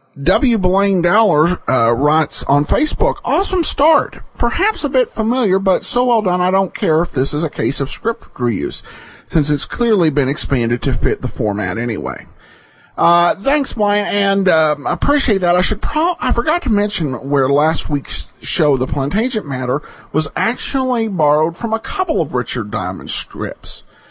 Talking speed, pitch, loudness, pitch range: 175 wpm, 175 Hz, -16 LUFS, 145-225 Hz